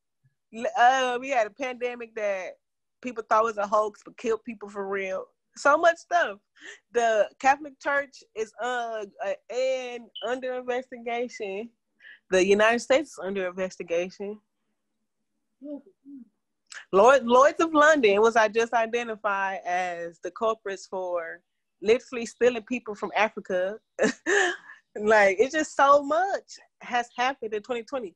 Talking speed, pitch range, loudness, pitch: 130 wpm, 210-270 Hz, -25 LUFS, 235 Hz